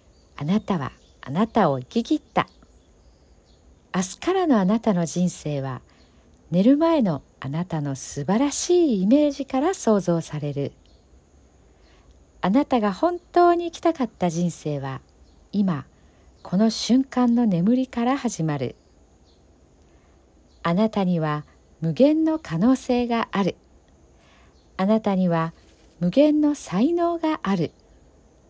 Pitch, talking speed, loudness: 175 Hz, 230 characters per minute, -23 LUFS